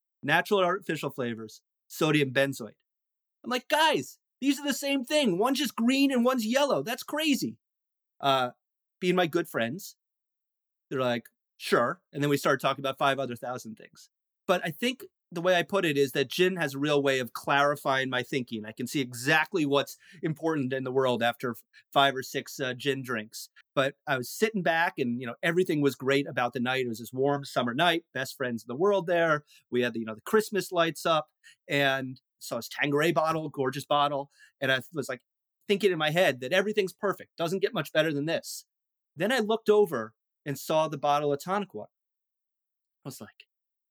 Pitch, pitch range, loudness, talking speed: 145 Hz, 135-185 Hz, -28 LUFS, 200 wpm